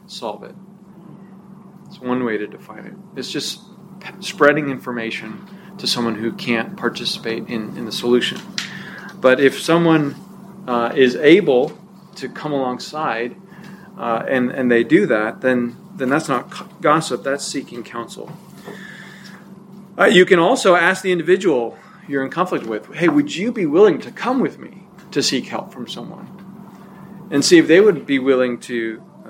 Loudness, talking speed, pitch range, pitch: -18 LUFS, 160 wpm, 135-195 Hz, 185 Hz